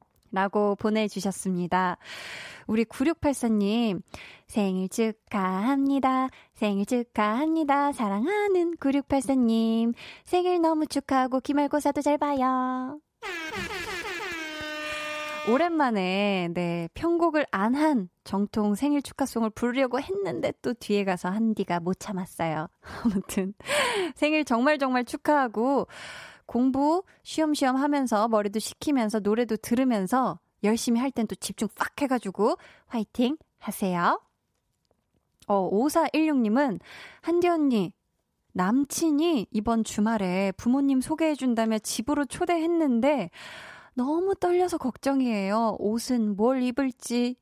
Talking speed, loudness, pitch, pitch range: 245 characters per minute, -26 LUFS, 250 Hz, 210-295 Hz